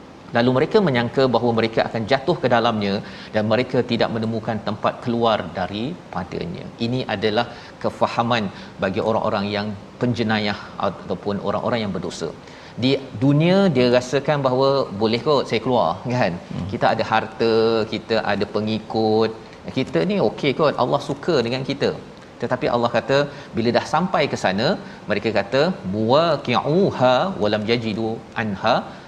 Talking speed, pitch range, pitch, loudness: 135 wpm, 110-130 Hz, 115 Hz, -21 LUFS